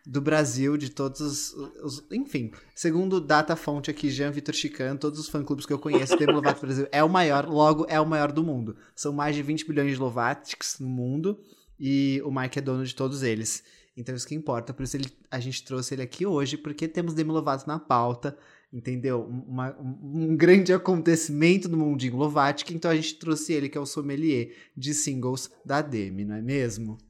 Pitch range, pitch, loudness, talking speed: 130-155 Hz, 145 Hz, -26 LUFS, 205 wpm